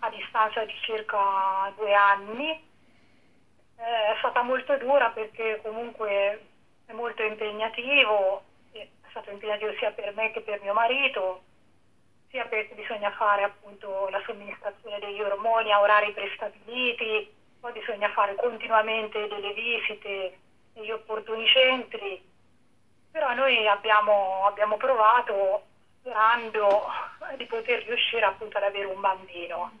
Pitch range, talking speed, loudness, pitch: 205-230 Hz, 120 wpm, -26 LUFS, 215 Hz